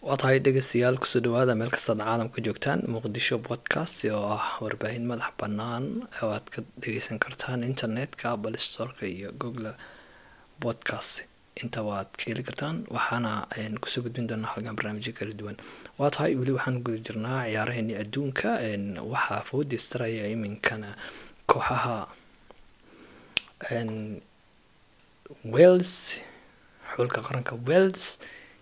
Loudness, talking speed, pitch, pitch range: -28 LUFS, 120 wpm, 115 Hz, 110-130 Hz